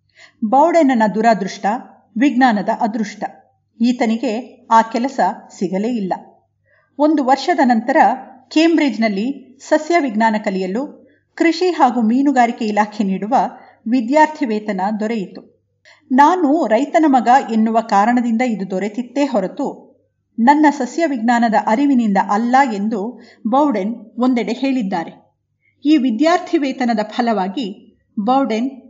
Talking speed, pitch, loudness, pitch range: 95 wpm, 245 Hz, -16 LUFS, 220-275 Hz